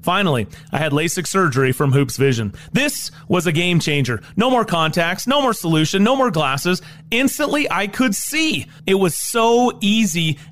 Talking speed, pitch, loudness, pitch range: 170 wpm, 180 Hz, -18 LUFS, 155-230 Hz